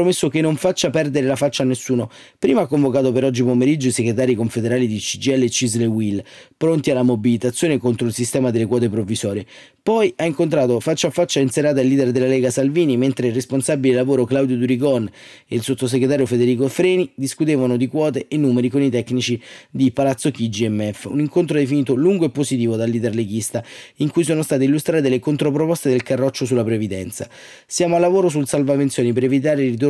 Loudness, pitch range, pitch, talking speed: -18 LUFS, 125-150 Hz, 130 Hz, 195 wpm